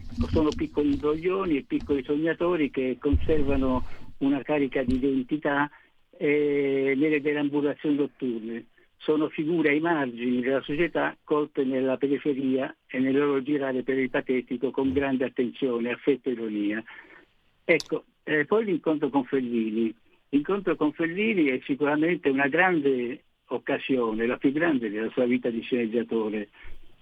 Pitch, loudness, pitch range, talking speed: 140 Hz, -26 LUFS, 130-150 Hz, 135 wpm